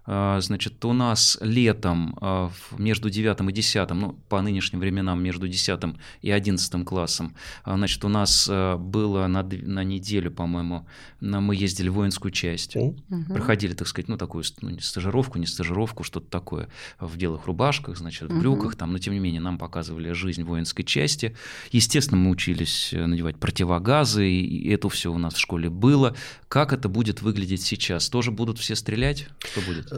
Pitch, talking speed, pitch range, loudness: 95 Hz, 165 wpm, 90-110 Hz, -24 LUFS